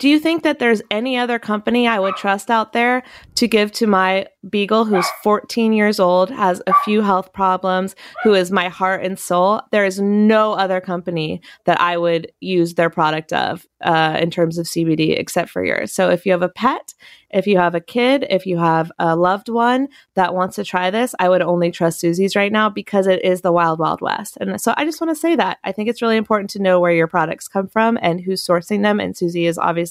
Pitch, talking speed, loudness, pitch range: 190 Hz, 235 wpm, -17 LUFS, 175-220 Hz